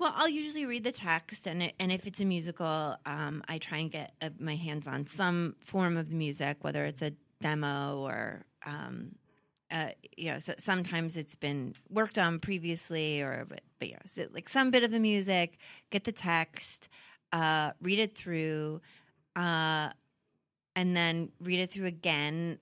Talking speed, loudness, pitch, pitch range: 170 wpm, -33 LUFS, 165 Hz, 150-185 Hz